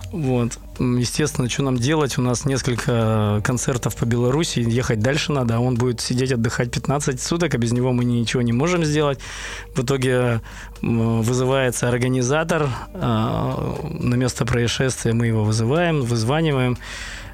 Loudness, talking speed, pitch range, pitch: -21 LUFS, 140 wpm, 115-135 Hz, 125 Hz